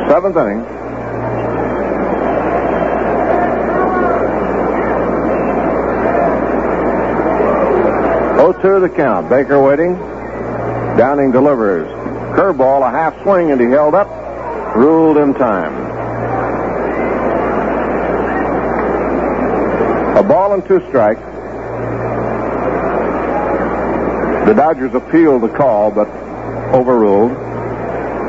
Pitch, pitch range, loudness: 140 Hz, 130-165 Hz, -14 LUFS